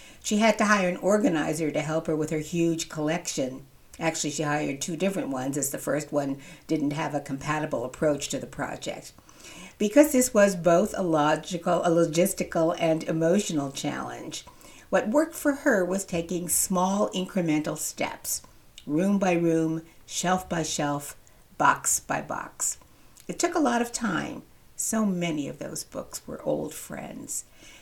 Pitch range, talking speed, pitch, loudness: 155-190 Hz, 160 wpm, 170 Hz, -26 LUFS